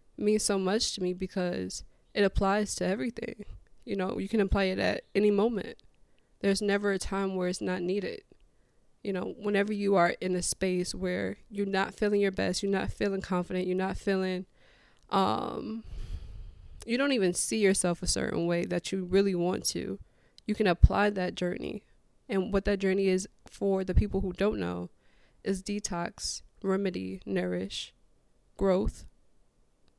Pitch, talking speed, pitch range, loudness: 190 Hz, 165 wpm, 180-200 Hz, -30 LUFS